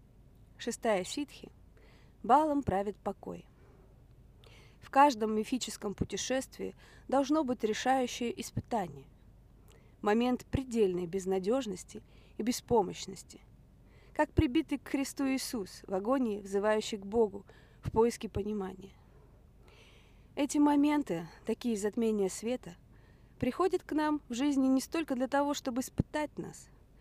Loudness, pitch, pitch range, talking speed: -32 LUFS, 235 Hz, 200-275 Hz, 105 wpm